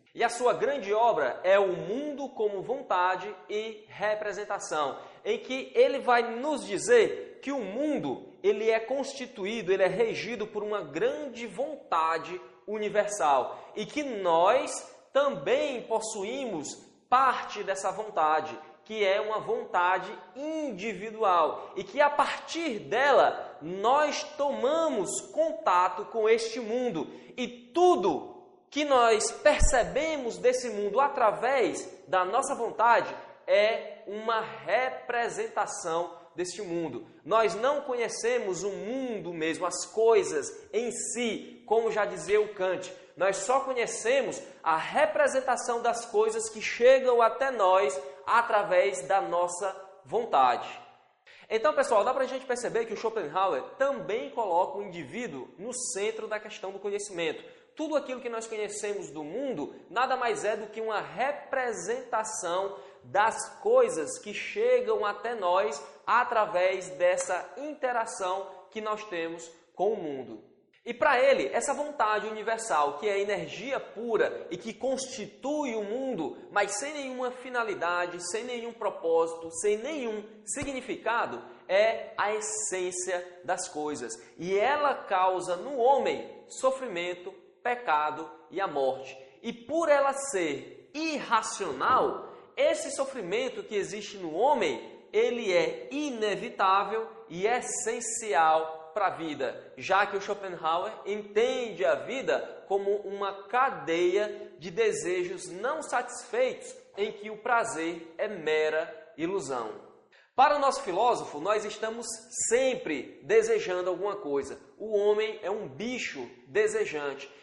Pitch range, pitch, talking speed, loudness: 195-285 Hz, 225 Hz, 125 wpm, -29 LUFS